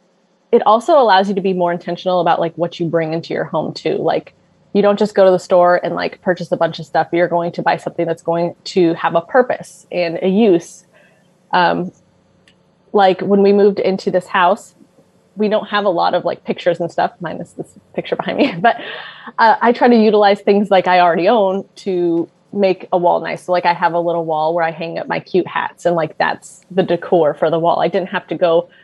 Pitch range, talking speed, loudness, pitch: 170-195 Hz, 235 wpm, -15 LUFS, 180 Hz